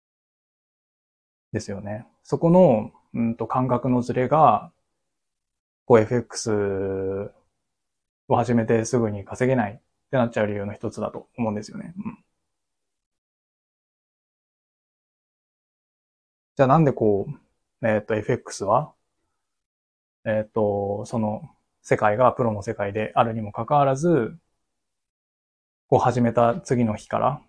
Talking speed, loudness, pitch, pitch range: 225 characters per minute, -23 LUFS, 115 Hz, 105-125 Hz